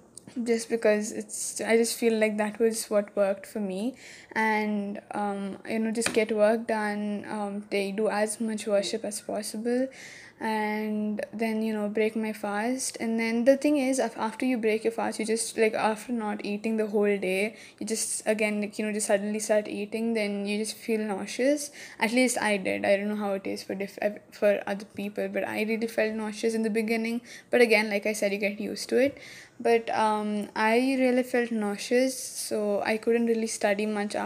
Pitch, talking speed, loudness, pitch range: 215 Hz, 205 wpm, -28 LUFS, 205-230 Hz